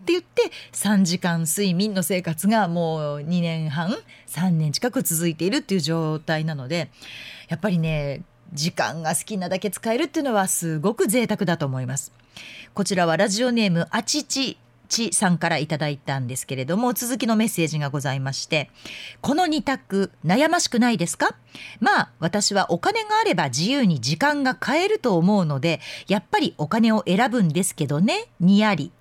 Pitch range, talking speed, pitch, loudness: 160-220 Hz, 345 characters per minute, 180 Hz, -22 LUFS